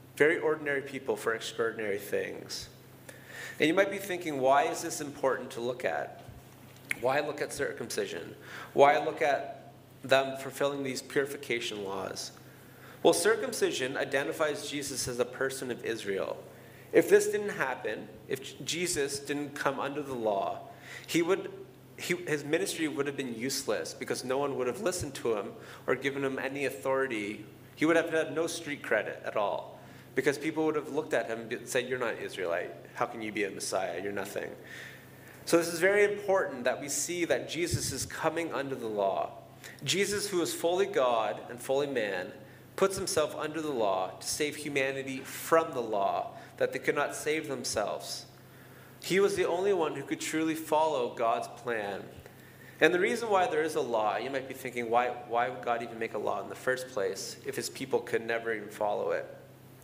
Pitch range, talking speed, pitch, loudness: 130-175 Hz, 185 wpm, 145 Hz, -31 LUFS